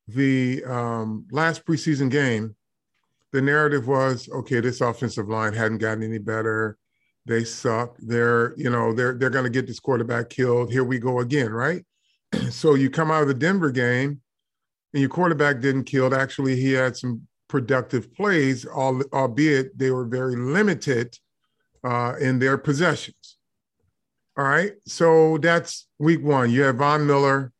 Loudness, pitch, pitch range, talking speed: -22 LUFS, 130 Hz, 120-145 Hz, 155 wpm